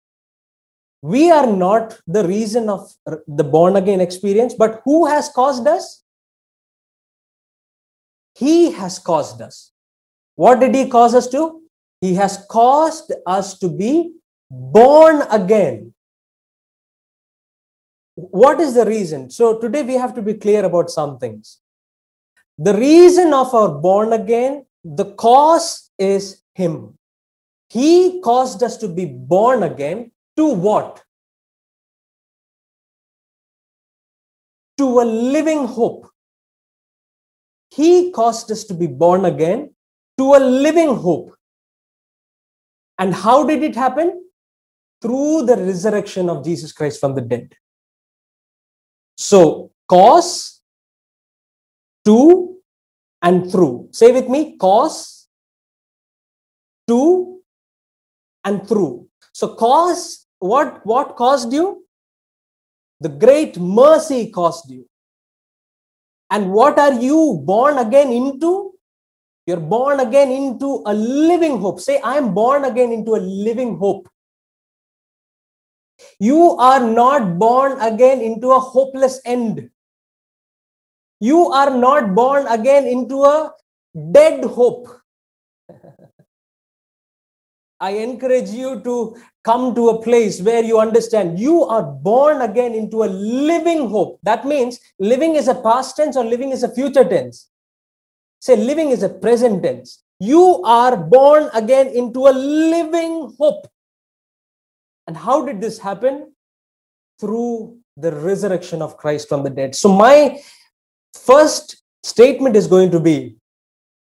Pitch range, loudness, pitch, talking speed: 195-280 Hz, -15 LUFS, 240 Hz, 120 wpm